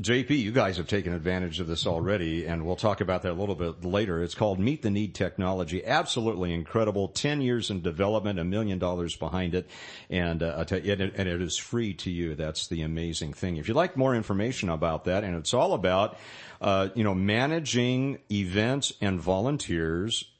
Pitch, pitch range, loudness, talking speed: 95 Hz, 85-110 Hz, -28 LUFS, 190 wpm